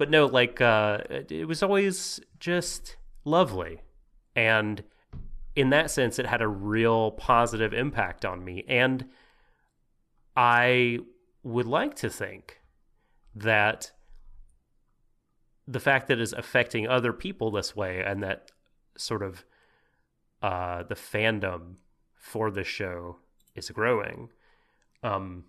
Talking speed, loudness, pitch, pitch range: 120 wpm, -27 LUFS, 110 Hz, 95-125 Hz